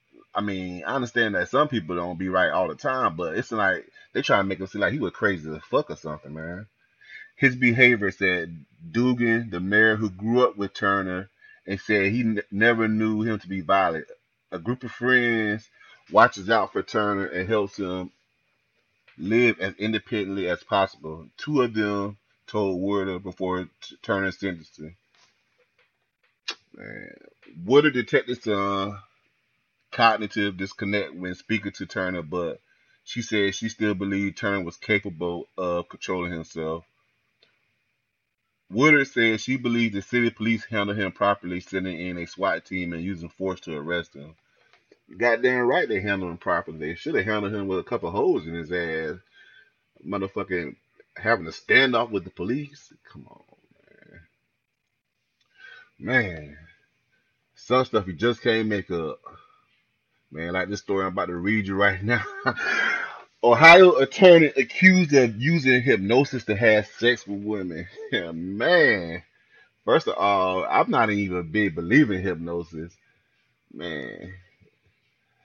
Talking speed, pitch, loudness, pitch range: 155 wpm, 100 Hz, -23 LUFS, 90-115 Hz